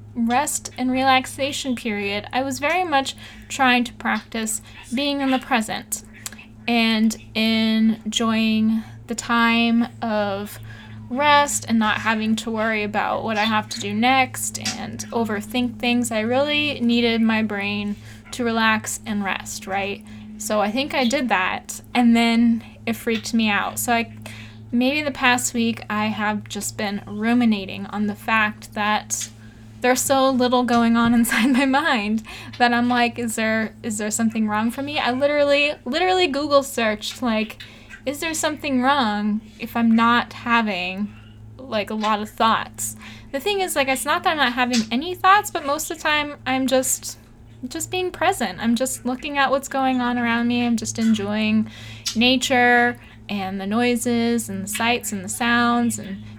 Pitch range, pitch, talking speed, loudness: 210-255 Hz, 230 Hz, 165 wpm, -21 LUFS